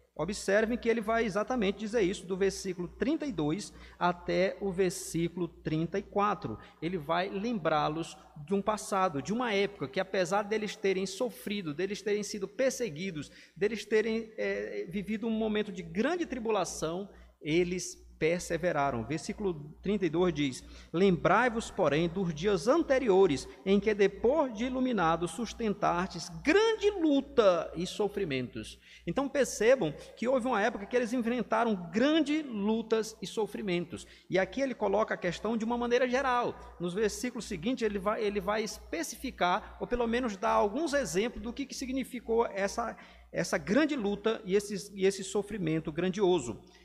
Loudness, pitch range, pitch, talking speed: -31 LUFS, 180-230 Hz, 205 Hz, 145 wpm